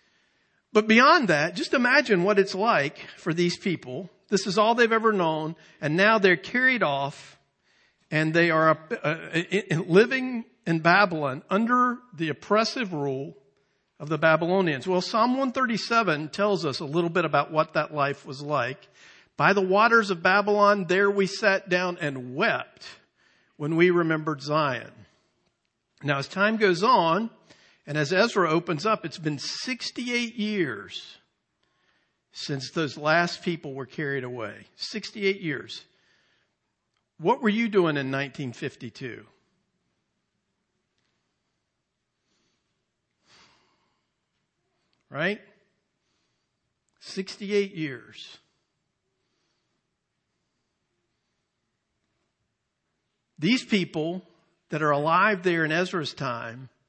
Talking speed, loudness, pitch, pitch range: 110 wpm, -24 LUFS, 175 Hz, 150-205 Hz